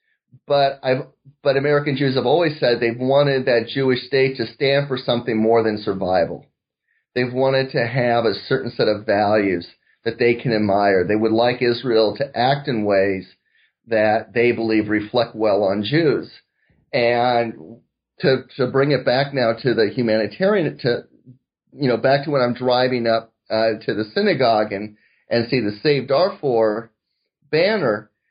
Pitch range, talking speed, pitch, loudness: 110-135 Hz, 165 wpm, 120 Hz, -19 LUFS